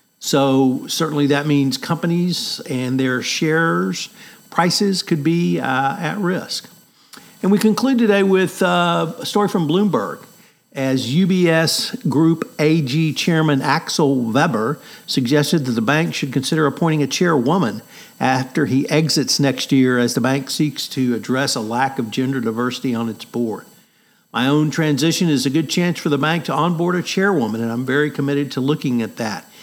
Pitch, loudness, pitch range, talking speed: 155 Hz, -18 LUFS, 135-175 Hz, 165 wpm